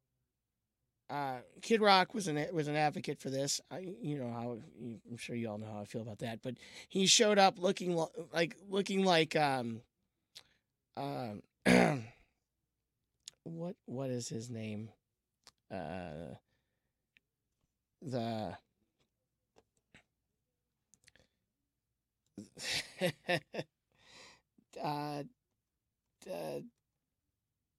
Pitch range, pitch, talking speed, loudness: 120-175 Hz, 135 Hz, 95 wpm, -35 LUFS